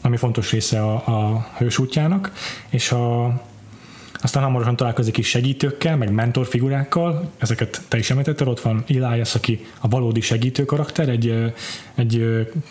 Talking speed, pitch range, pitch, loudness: 140 wpm, 115-135 Hz, 120 Hz, -21 LUFS